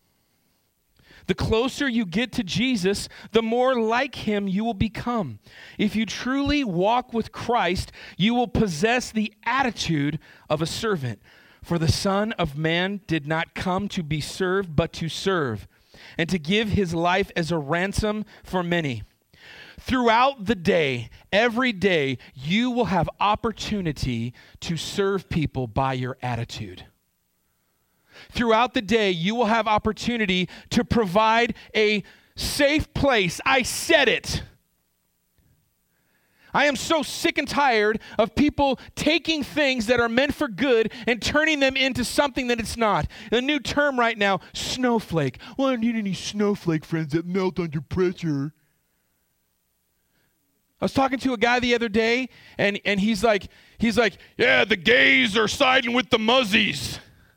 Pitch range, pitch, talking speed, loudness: 170-240 Hz, 210 Hz, 150 wpm, -23 LUFS